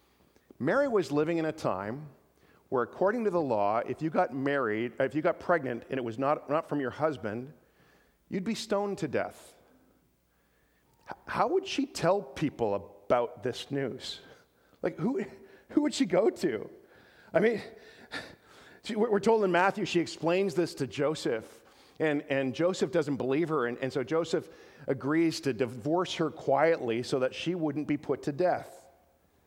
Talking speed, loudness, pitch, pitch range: 170 wpm, -30 LUFS, 155 Hz, 130-180 Hz